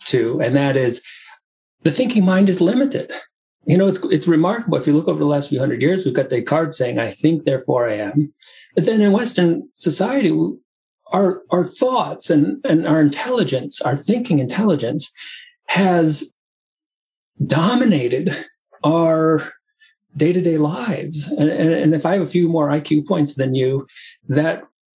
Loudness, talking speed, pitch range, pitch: -18 LUFS, 155 wpm, 150-195 Hz, 165 Hz